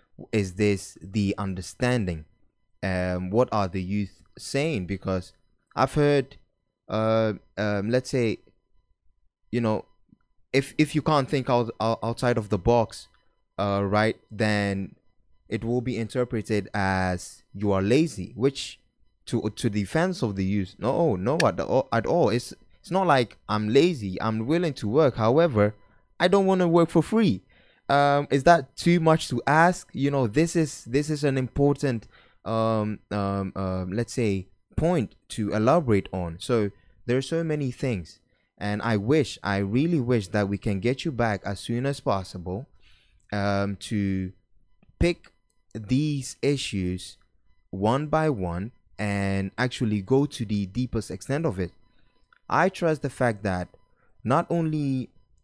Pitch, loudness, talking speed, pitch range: 110 Hz, -25 LUFS, 155 wpm, 100-135 Hz